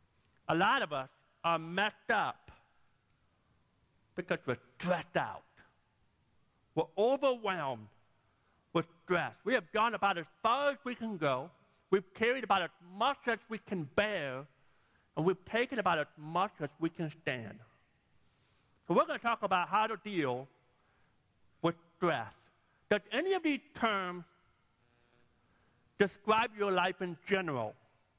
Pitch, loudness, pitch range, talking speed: 180 Hz, -34 LUFS, 135-210 Hz, 140 wpm